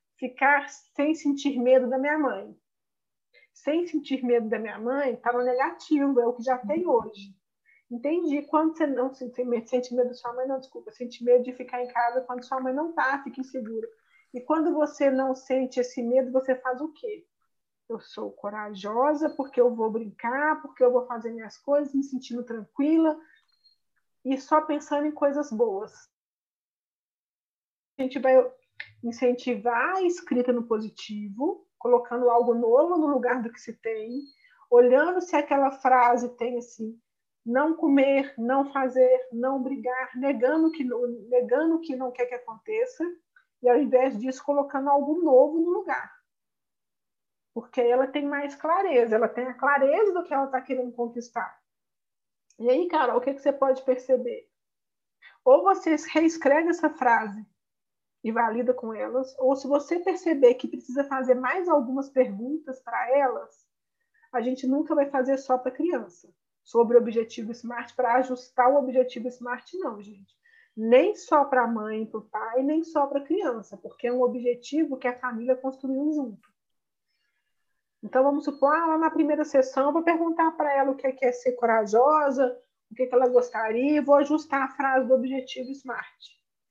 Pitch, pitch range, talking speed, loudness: 260 Hz, 245-295 Hz, 170 wpm, -25 LUFS